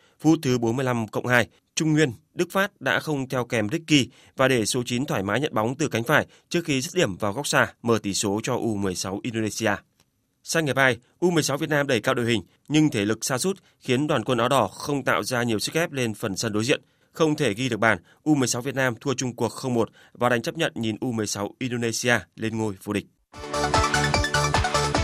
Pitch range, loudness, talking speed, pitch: 110-145 Hz, -24 LUFS, 220 wpm, 125 Hz